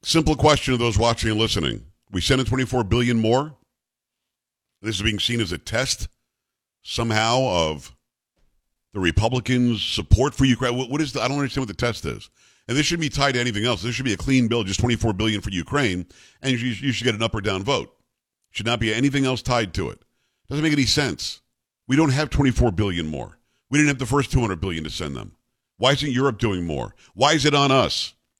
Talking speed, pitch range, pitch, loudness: 220 wpm, 110-135 Hz, 120 Hz, -22 LUFS